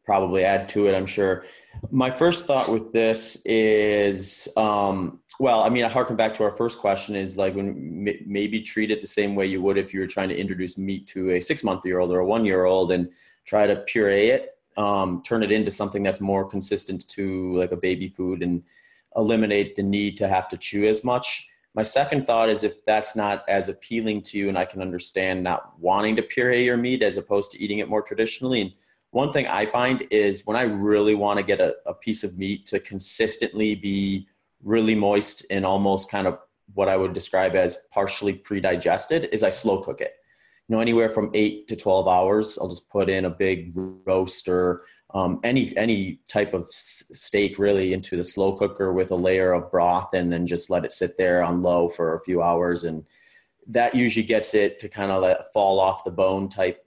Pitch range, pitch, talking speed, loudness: 95-110 Hz, 100 Hz, 215 wpm, -23 LUFS